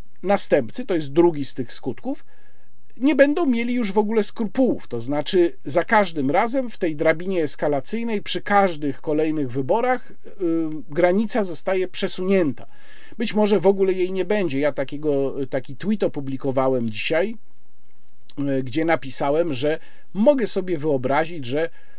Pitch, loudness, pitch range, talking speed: 175 Hz, -22 LUFS, 145-215 Hz, 140 wpm